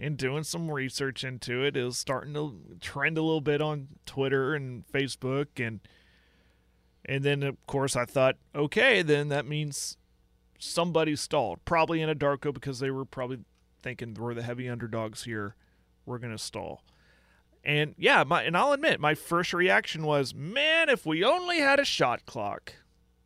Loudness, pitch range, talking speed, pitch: -28 LUFS, 120-150 Hz, 175 wpm, 140 Hz